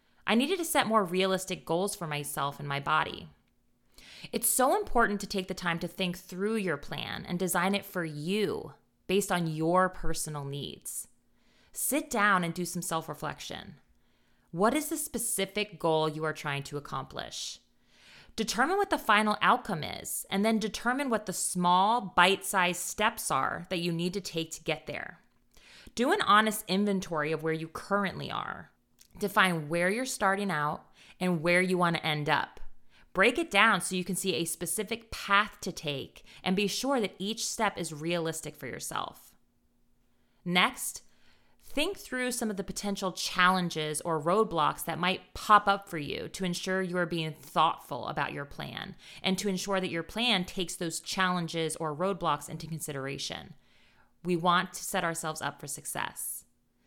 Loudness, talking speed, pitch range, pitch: -30 LUFS, 175 wpm, 165-205 Hz, 185 Hz